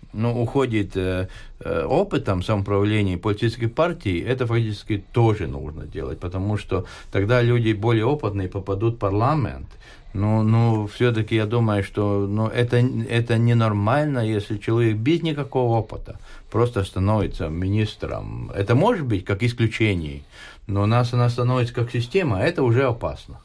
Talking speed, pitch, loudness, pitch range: 145 wpm, 110 Hz, -22 LUFS, 100-120 Hz